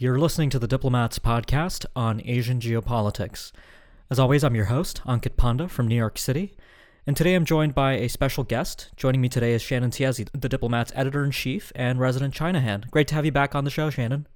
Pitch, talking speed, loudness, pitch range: 130 Hz, 210 wpm, -24 LUFS, 120-145 Hz